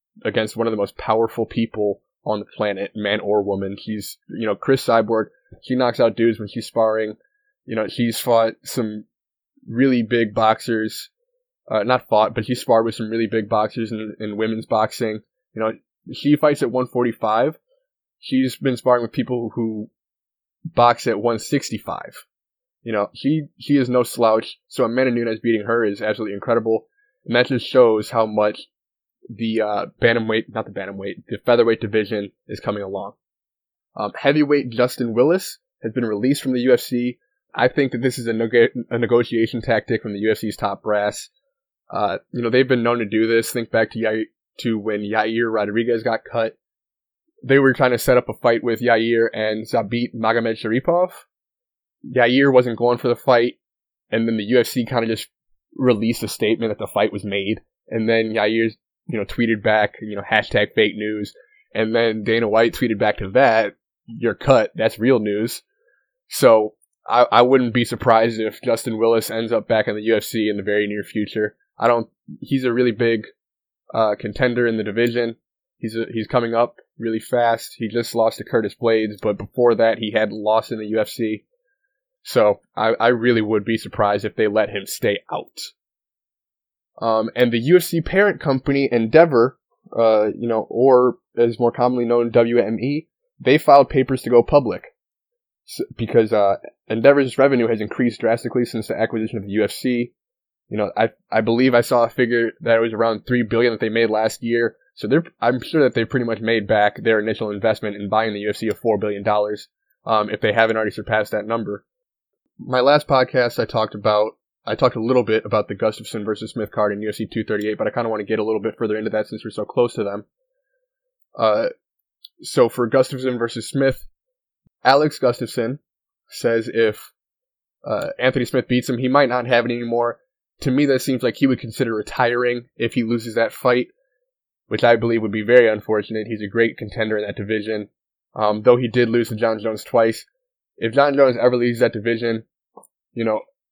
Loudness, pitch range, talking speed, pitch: -19 LUFS, 110-125 Hz, 195 wpm, 115 Hz